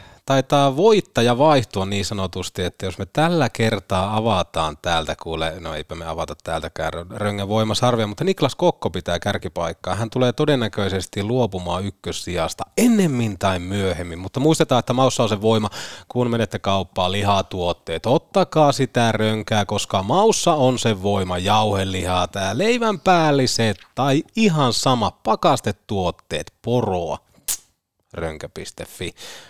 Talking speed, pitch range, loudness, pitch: 130 wpm, 95-130 Hz, -20 LUFS, 105 Hz